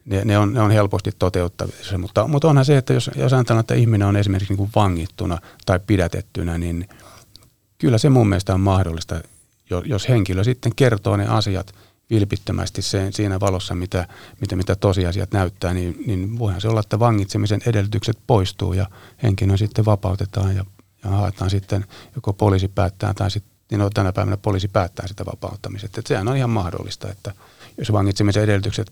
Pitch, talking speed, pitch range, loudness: 100 Hz, 180 wpm, 95-110 Hz, -20 LUFS